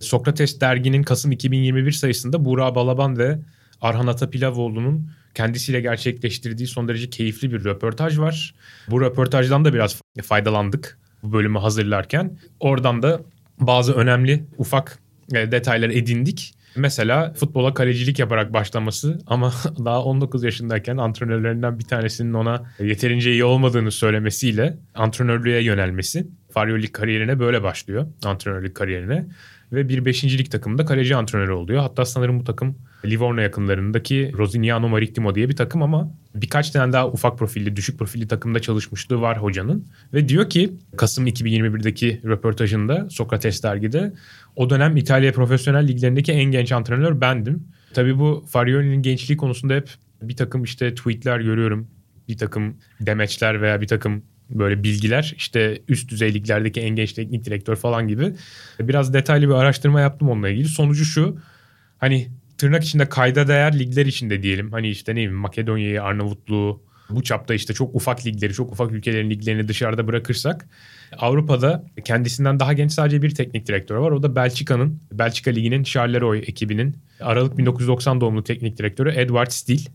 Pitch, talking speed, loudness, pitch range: 125 Hz, 145 wpm, -20 LUFS, 110-135 Hz